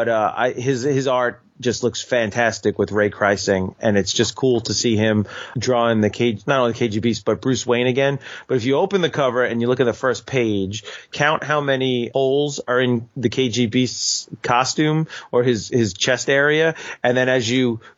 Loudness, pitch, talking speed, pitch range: -19 LUFS, 120 Hz, 205 wpm, 115-130 Hz